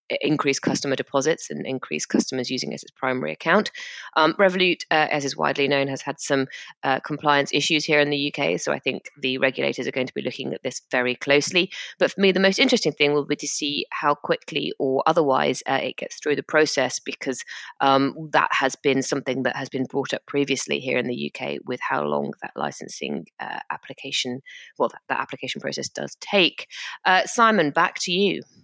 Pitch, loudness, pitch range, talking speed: 145 Hz, -23 LUFS, 135-165 Hz, 205 wpm